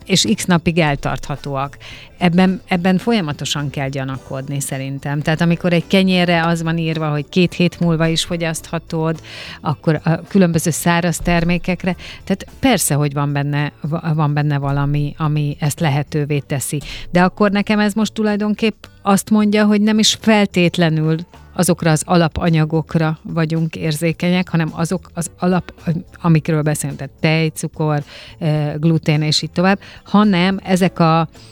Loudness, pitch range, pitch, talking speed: -17 LUFS, 150-180 Hz, 165 Hz, 140 wpm